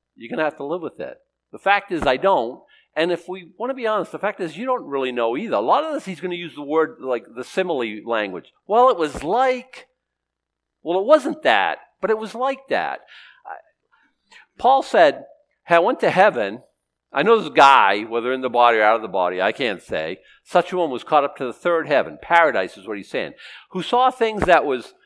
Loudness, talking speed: -20 LUFS, 230 wpm